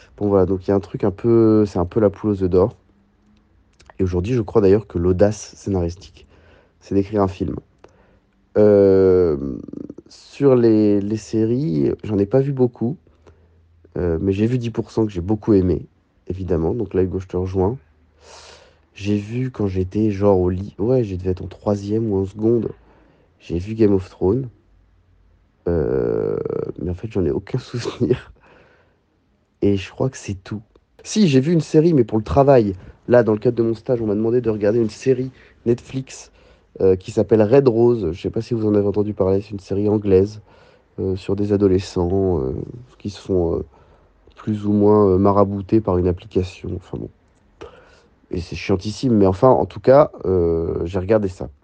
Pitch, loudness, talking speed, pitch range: 100 Hz, -19 LUFS, 190 wpm, 95-115 Hz